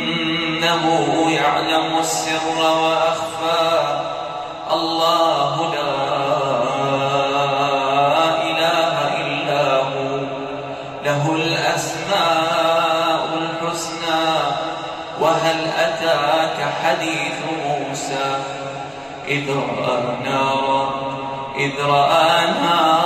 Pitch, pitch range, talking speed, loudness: 160 Hz, 135-165 Hz, 55 wpm, -19 LUFS